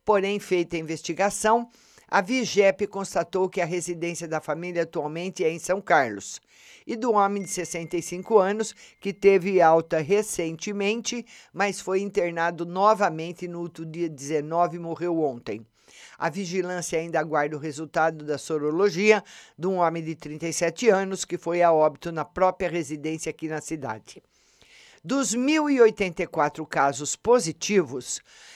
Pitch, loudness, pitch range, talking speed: 175 Hz, -25 LUFS, 160-200 Hz, 140 wpm